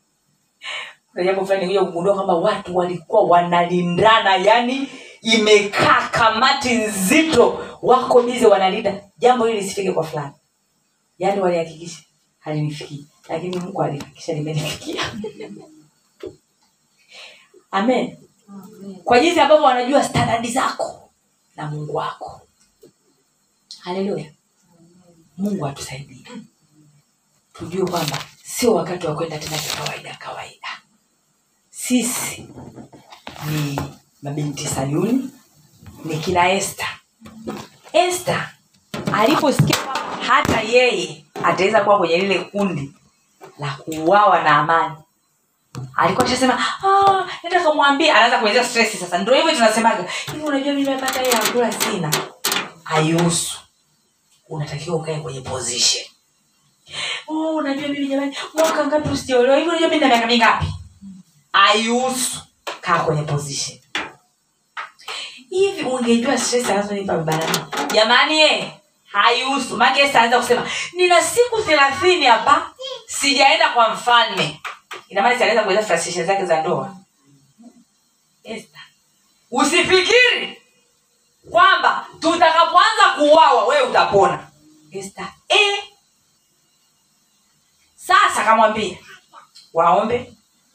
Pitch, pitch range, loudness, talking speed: 215 Hz, 170-270 Hz, -17 LUFS, 55 wpm